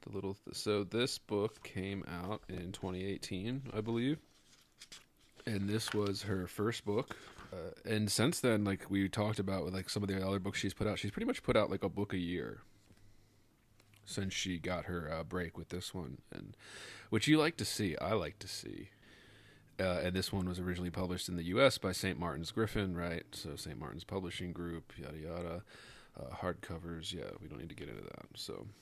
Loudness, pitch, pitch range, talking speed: -38 LUFS, 100 Hz, 90-105 Hz, 200 wpm